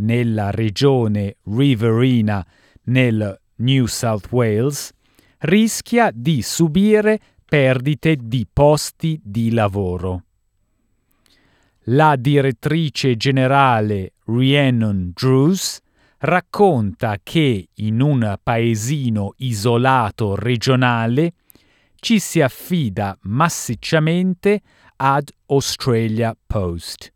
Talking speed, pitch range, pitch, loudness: 75 wpm, 110-145 Hz, 125 Hz, -18 LUFS